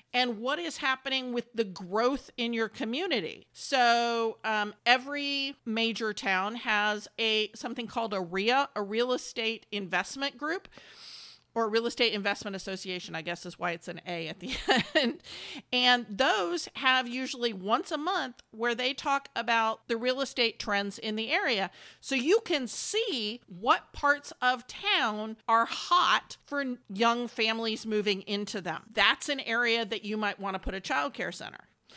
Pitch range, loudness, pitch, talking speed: 210-265 Hz, -29 LUFS, 235 Hz, 165 wpm